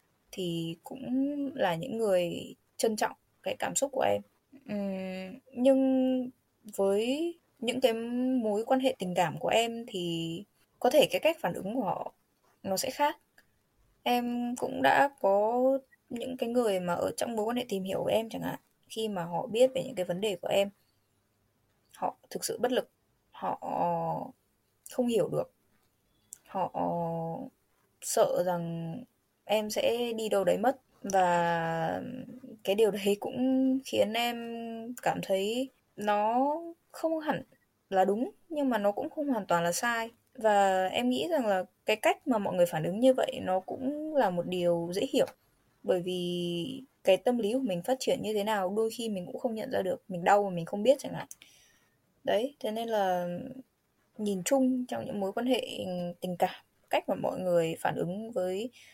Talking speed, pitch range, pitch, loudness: 180 wpm, 185-255 Hz, 220 Hz, -30 LUFS